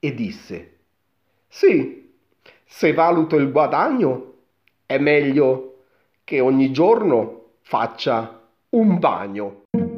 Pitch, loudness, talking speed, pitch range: 145 Hz, -19 LUFS, 90 wpm, 130-170 Hz